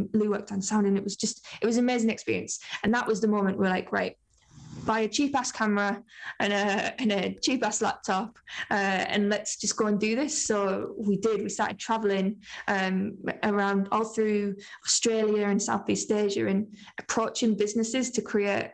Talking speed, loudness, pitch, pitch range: 185 wpm, -27 LUFS, 210 Hz, 200-220 Hz